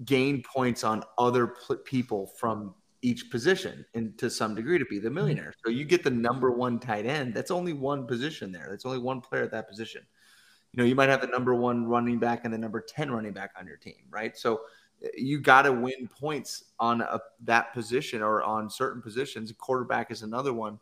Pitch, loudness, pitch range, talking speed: 120 Hz, -28 LUFS, 115-130 Hz, 215 wpm